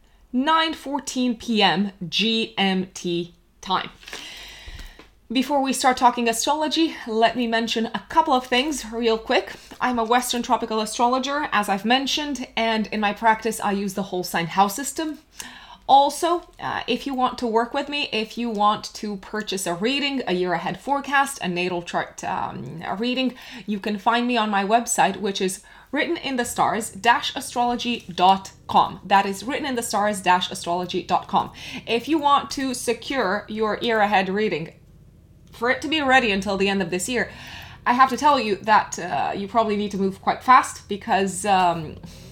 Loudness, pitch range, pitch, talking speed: -22 LUFS, 195-260 Hz, 230 Hz, 160 wpm